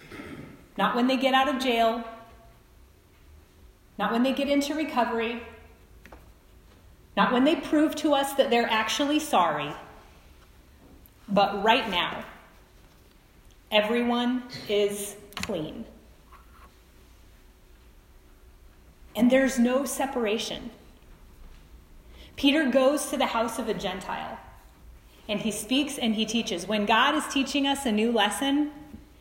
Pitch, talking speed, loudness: 220 Hz, 115 wpm, -25 LUFS